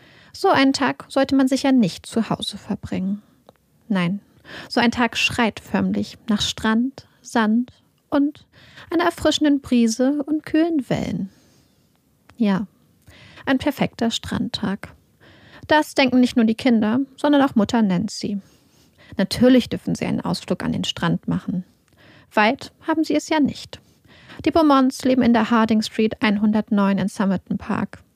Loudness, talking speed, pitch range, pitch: -20 LUFS, 145 wpm, 210-275 Hz, 235 Hz